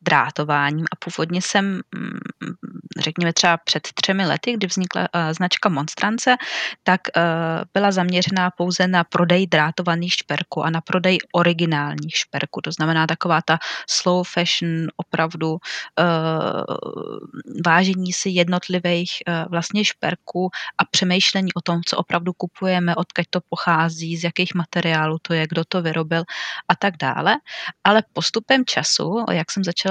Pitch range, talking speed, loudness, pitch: 165-185 Hz, 140 wpm, -20 LUFS, 175 Hz